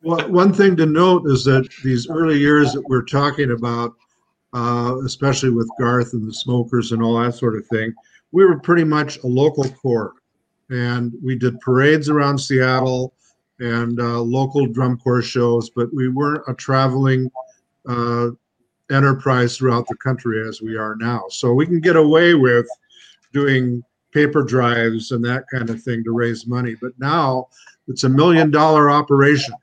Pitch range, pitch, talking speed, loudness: 120-145 Hz, 130 Hz, 170 wpm, -17 LUFS